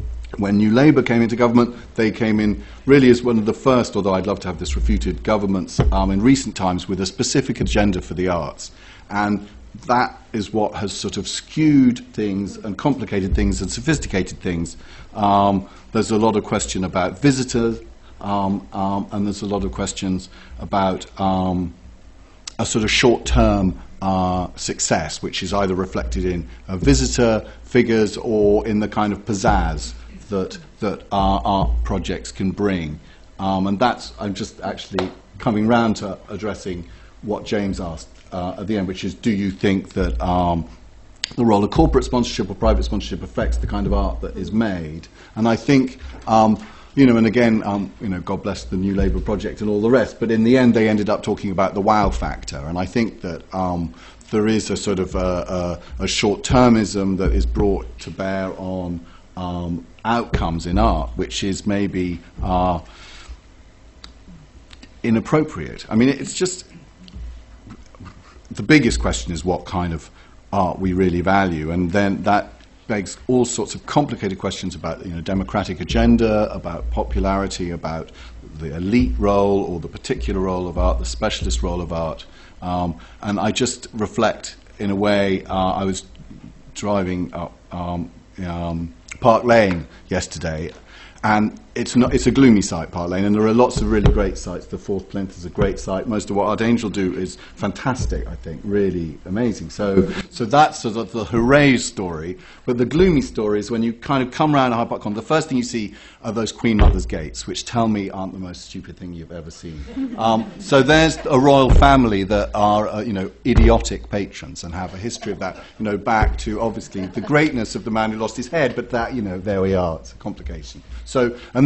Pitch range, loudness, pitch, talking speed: 90-110 Hz, -20 LUFS, 100 Hz, 190 wpm